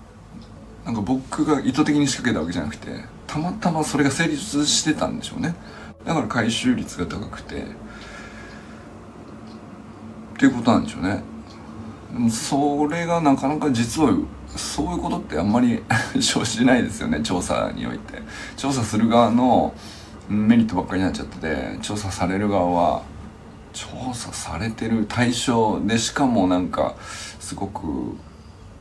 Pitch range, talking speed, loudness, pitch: 105-145 Hz, 300 characters per minute, -22 LUFS, 120 Hz